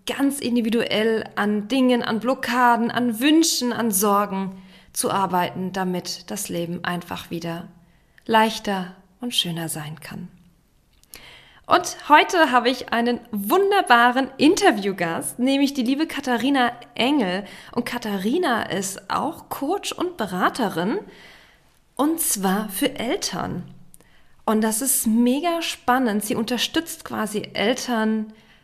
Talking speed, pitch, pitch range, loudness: 115 wpm, 235 Hz, 200-265 Hz, -22 LUFS